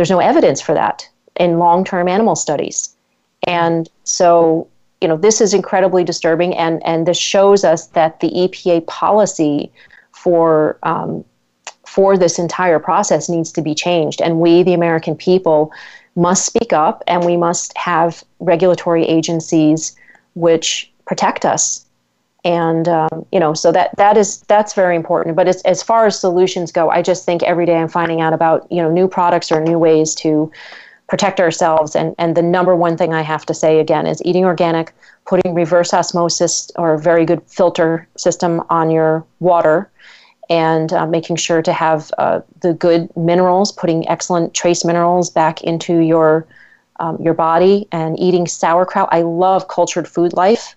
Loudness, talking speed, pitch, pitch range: -14 LUFS, 170 wpm, 170 Hz, 165-180 Hz